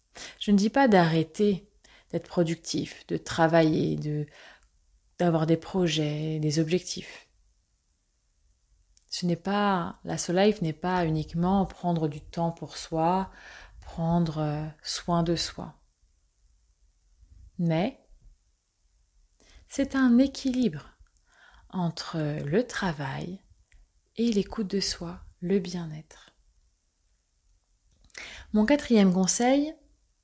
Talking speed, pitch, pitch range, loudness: 95 wpm, 165 Hz, 145-190 Hz, -27 LUFS